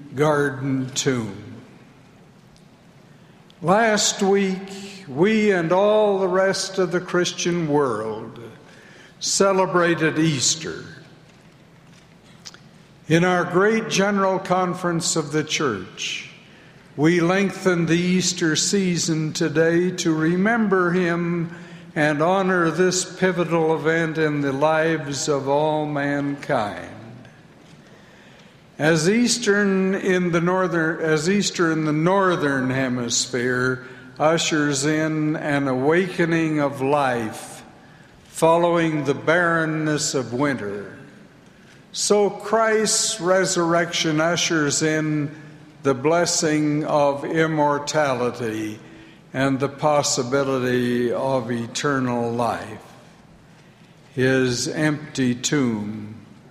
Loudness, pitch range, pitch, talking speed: -21 LUFS, 145-180 Hz, 160 Hz, 90 wpm